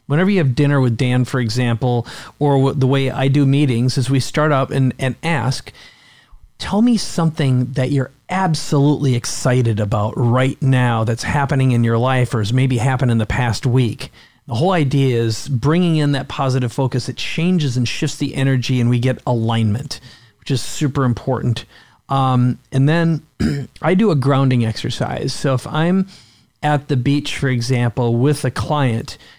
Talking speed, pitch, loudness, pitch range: 175 wpm, 130 Hz, -17 LUFS, 125-145 Hz